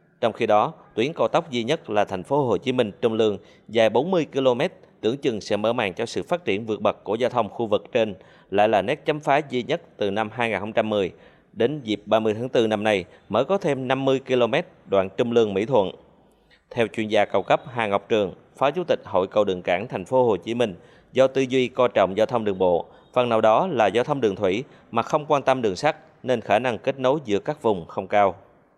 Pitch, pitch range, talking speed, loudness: 115 Hz, 105-130 Hz, 240 wpm, -23 LUFS